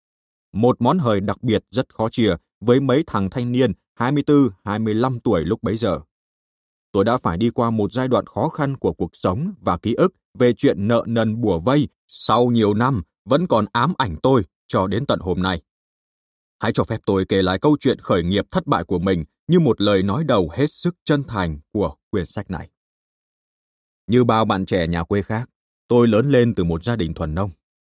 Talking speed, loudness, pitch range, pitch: 205 wpm, -20 LUFS, 95-125 Hz, 110 Hz